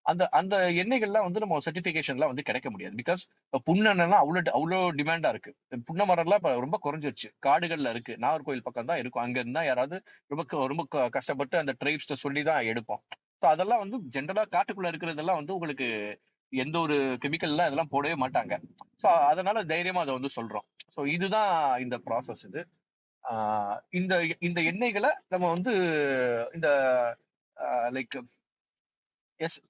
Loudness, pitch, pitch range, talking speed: -28 LUFS, 160 Hz, 130-185 Hz, 140 wpm